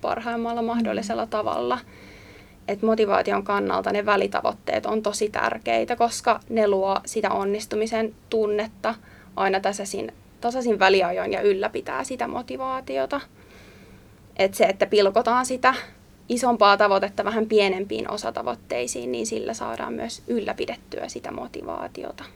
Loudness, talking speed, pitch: -24 LUFS, 115 wpm, 205 Hz